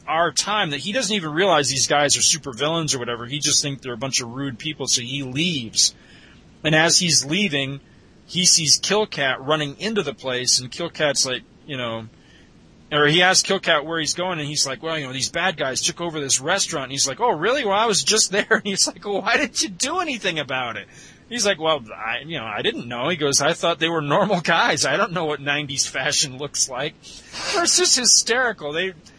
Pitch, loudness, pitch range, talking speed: 155 Hz, -20 LUFS, 140-190 Hz, 235 wpm